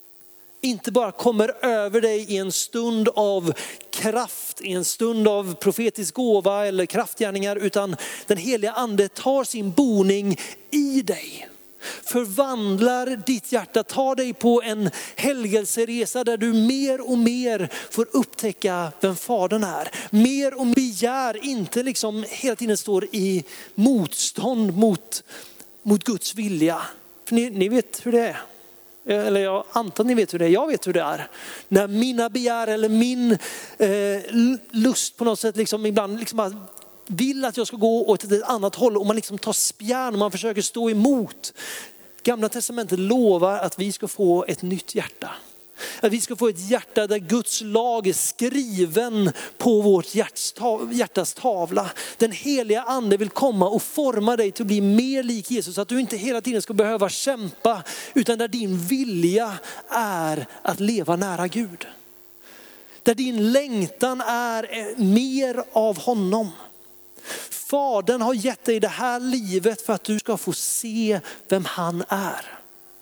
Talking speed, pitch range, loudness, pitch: 160 wpm, 200-245 Hz, -22 LUFS, 220 Hz